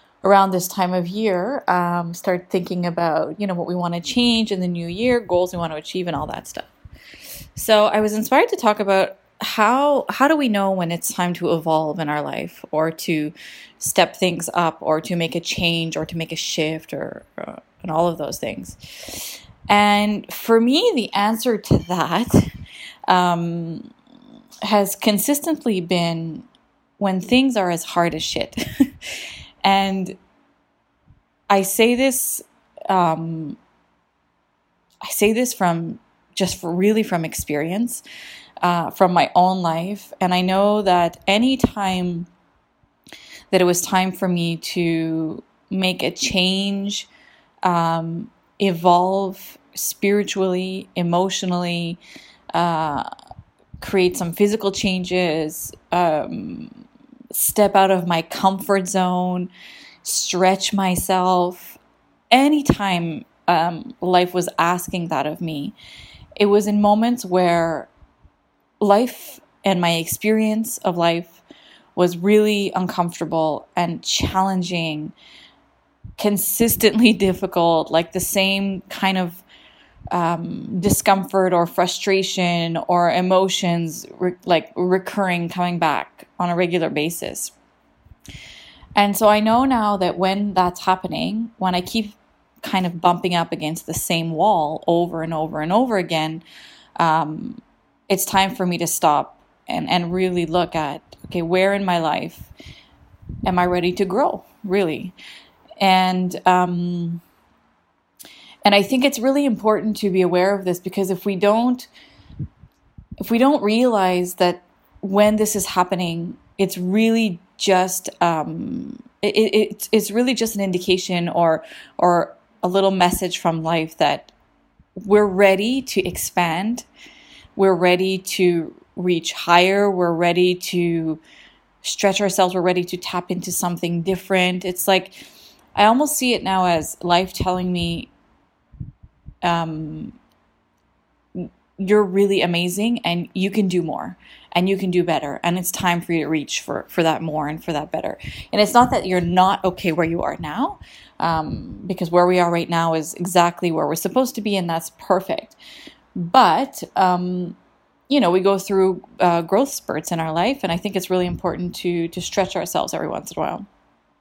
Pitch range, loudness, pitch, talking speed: 175-205 Hz, -20 LUFS, 185 Hz, 145 wpm